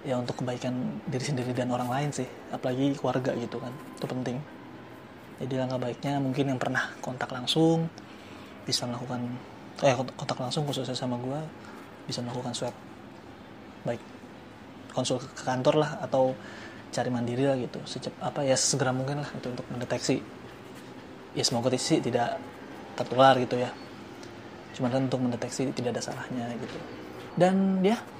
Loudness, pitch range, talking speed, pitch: -29 LUFS, 125-140 Hz, 150 wpm, 130 Hz